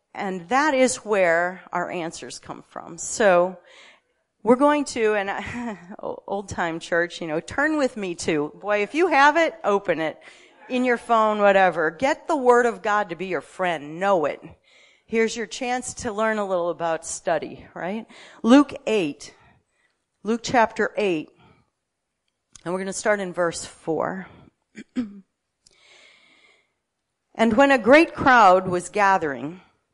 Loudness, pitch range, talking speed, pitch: -22 LUFS, 180-245 Hz, 150 wpm, 210 Hz